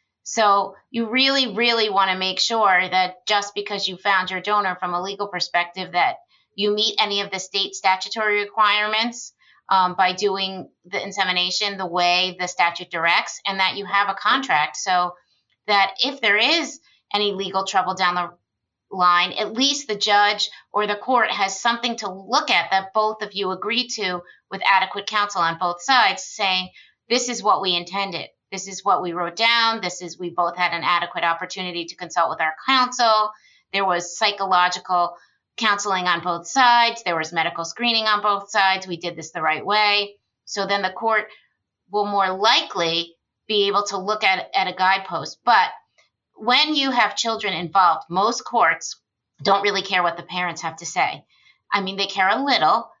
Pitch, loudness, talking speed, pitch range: 195 Hz, -20 LUFS, 185 wpm, 180-215 Hz